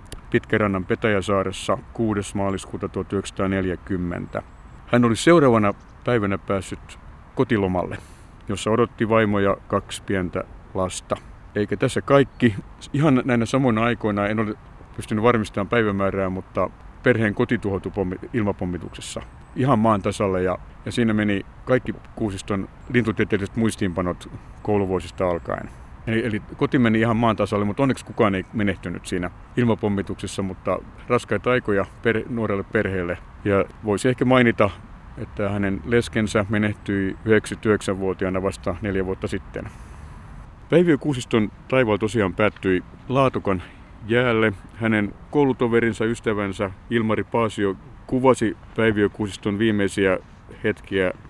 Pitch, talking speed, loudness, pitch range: 105 Hz, 110 wpm, -22 LUFS, 95-115 Hz